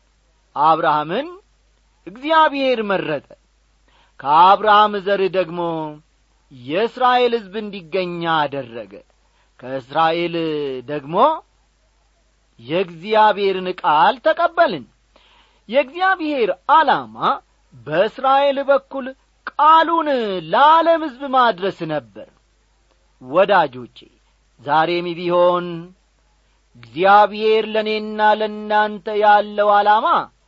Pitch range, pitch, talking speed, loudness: 170-265 Hz, 205 Hz, 65 wpm, -17 LUFS